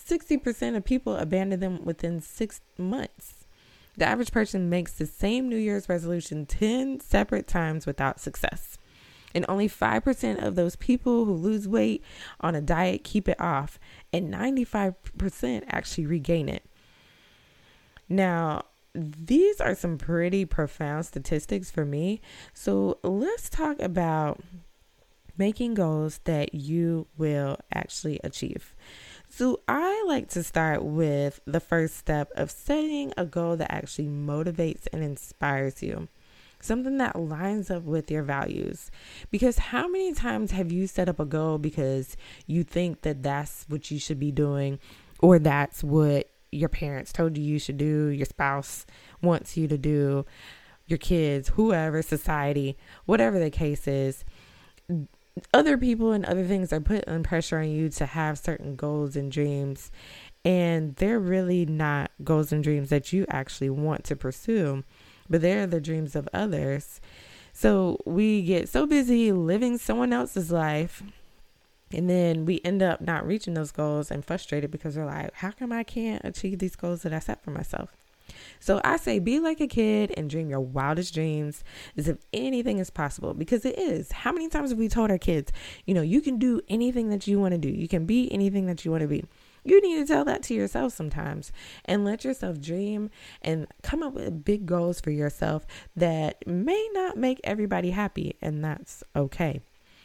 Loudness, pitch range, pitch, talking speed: -27 LUFS, 150-205 Hz, 170 Hz, 165 wpm